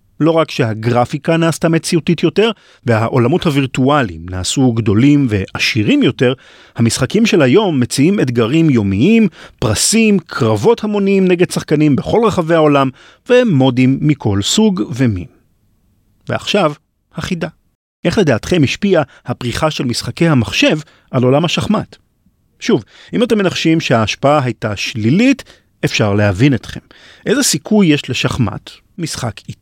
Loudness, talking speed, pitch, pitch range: -14 LUFS, 115 wpm, 145 Hz, 120-175 Hz